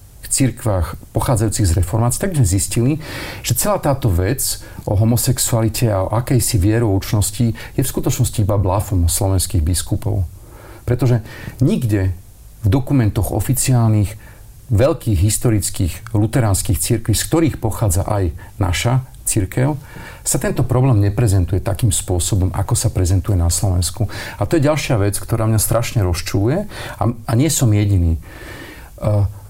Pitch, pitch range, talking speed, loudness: 110 Hz, 100-120 Hz, 125 wpm, -17 LUFS